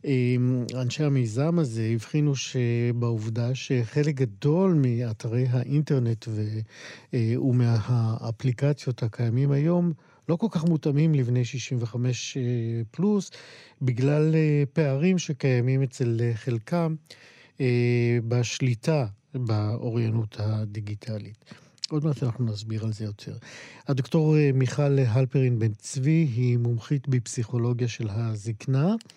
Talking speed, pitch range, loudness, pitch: 95 wpm, 115-145 Hz, -26 LUFS, 125 Hz